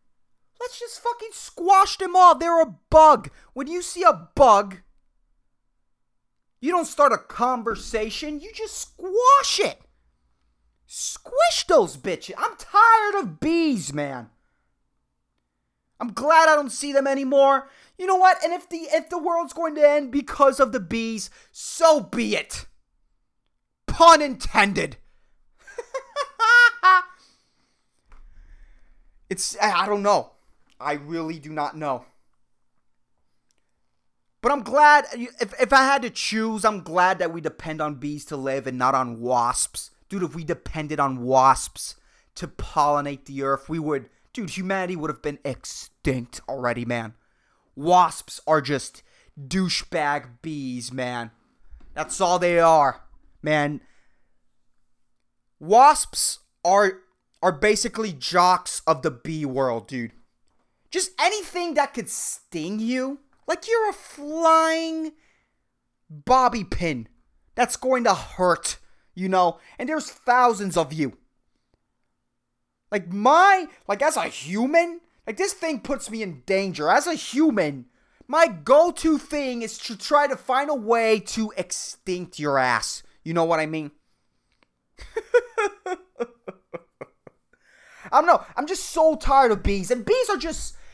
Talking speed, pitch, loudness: 135 wpm, 230 Hz, -21 LUFS